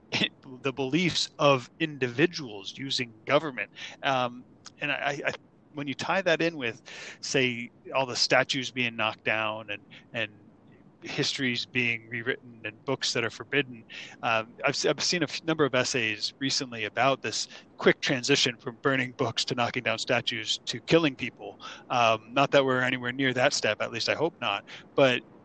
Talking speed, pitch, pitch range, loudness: 165 wpm, 130 Hz, 120-140 Hz, -27 LUFS